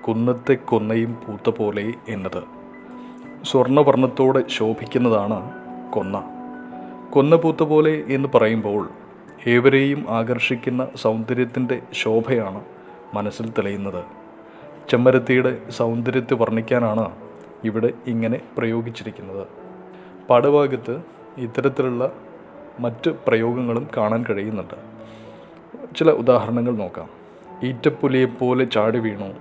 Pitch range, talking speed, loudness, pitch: 110-130 Hz, 75 wpm, -20 LUFS, 120 Hz